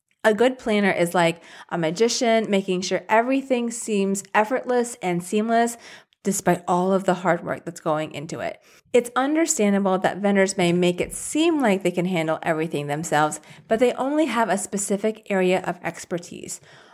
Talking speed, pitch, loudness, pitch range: 165 wpm, 190 Hz, -22 LUFS, 175-230 Hz